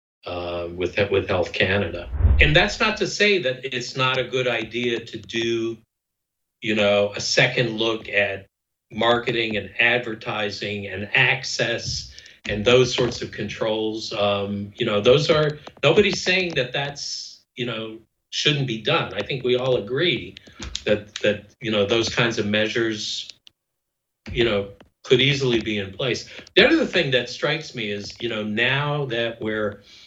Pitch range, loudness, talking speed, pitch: 105-125 Hz, -22 LUFS, 160 wpm, 115 Hz